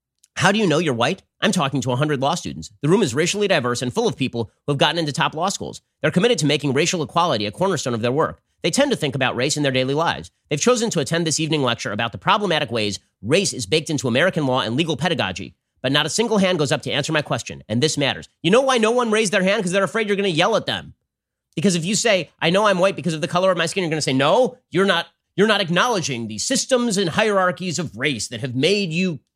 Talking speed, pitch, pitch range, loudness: 275 wpm, 160 Hz, 135-195 Hz, -20 LUFS